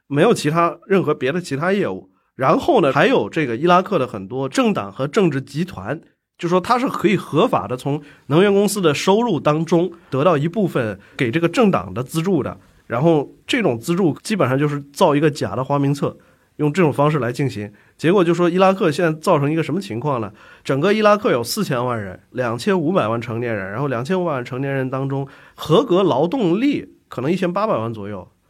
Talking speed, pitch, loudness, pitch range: 325 characters per minute, 150 Hz, -19 LUFS, 125-175 Hz